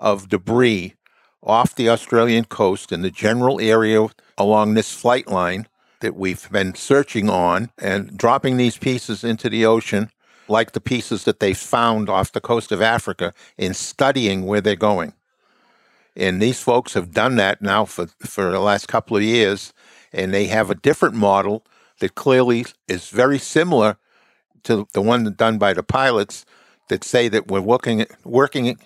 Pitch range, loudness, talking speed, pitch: 100-120 Hz, -19 LUFS, 165 wpm, 110 Hz